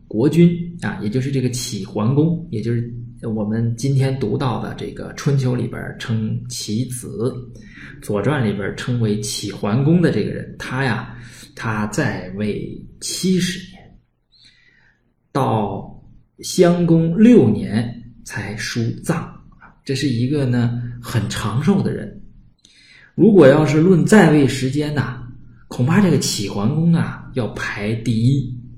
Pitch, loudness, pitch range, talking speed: 125 Hz, -18 LUFS, 115-150 Hz, 190 characters per minute